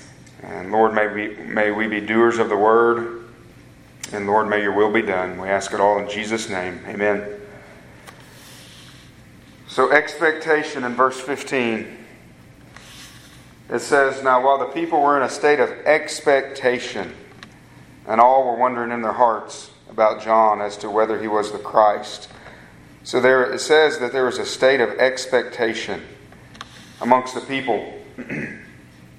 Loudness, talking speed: -19 LUFS, 150 wpm